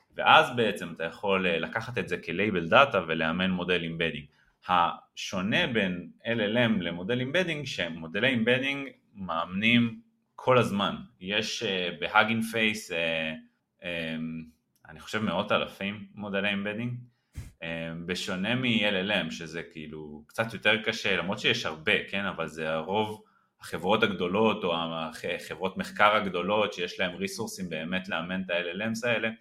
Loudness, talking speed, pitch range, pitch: -28 LUFS, 120 wpm, 80-110 Hz, 95 Hz